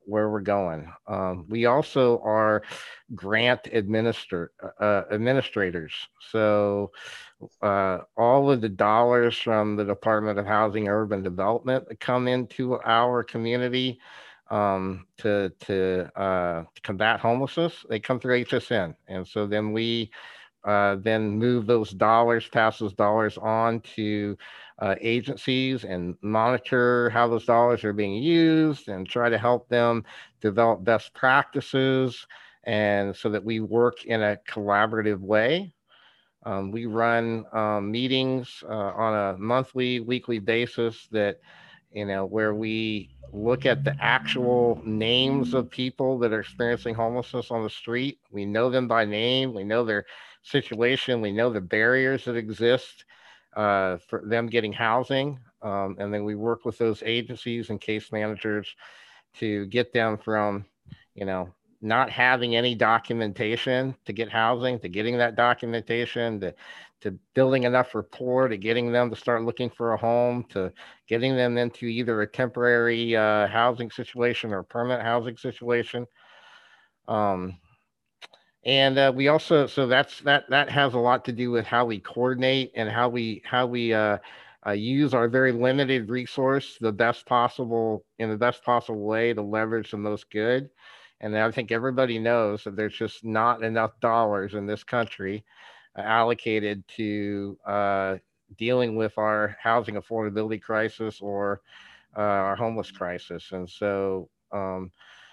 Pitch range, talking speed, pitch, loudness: 105-120 Hz, 150 wpm, 115 Hz, -25 LUFS